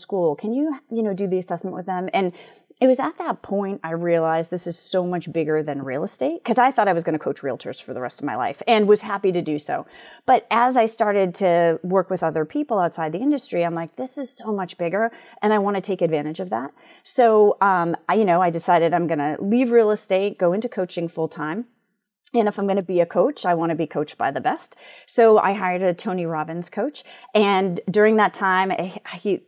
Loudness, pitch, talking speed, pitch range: -21 LUFS, 190 Hz, 245 wpm, 170-225 Hz